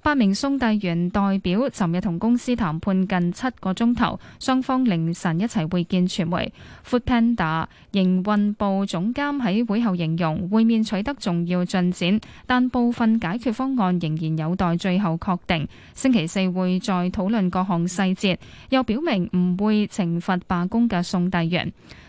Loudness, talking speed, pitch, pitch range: -22 LUFS, 260 characters per minute, 195 Hz, 180-230 Hz